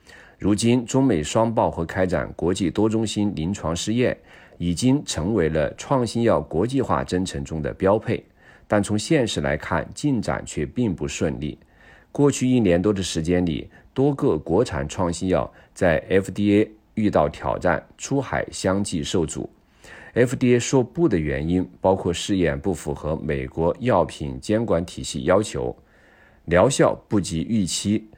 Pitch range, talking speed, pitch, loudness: 85-115 Hz, 230 characters per minute, 95 Hz, -22 LUFS